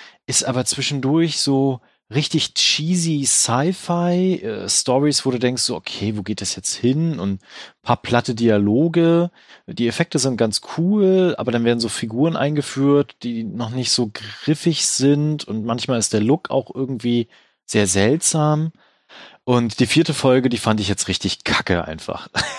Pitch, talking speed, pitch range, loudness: 130 Hz, 160 wpm, 115-155 Hz, -19 LUFS